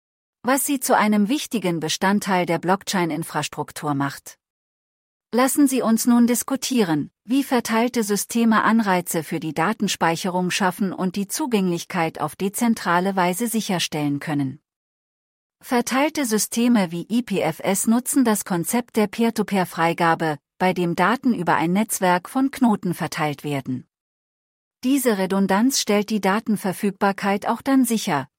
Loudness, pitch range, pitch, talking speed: -21 LUFS, 170-230 Hz, 195 Hz, 125 wpm